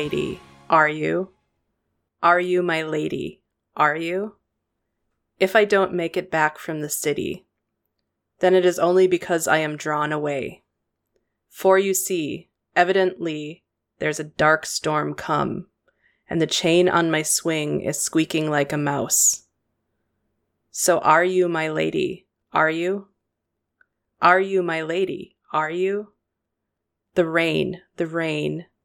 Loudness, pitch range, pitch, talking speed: -21 LUFS, 145-180 Hz, 160 Hz, 130 wpm